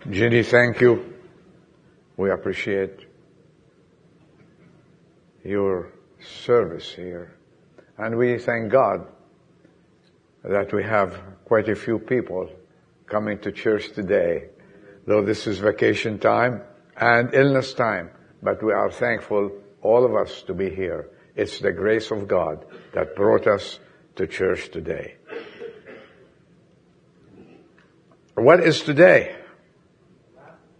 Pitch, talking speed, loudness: 120 Hz, 105 wpm, -21 LUFS